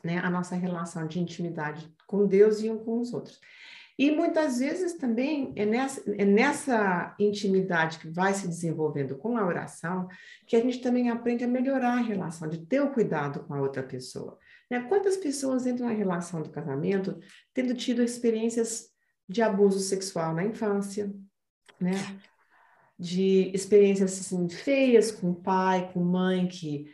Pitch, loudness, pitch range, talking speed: 200 Hz, -27 LUFS, 175-240 Hz, 165 wpm